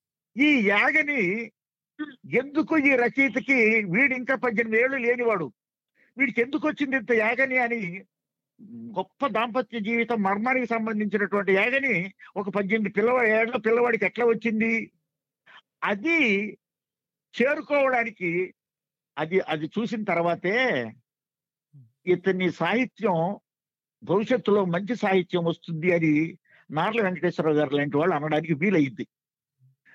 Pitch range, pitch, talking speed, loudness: 170-240 Hz, 210 Hz, 90 wpm, -24 LUFS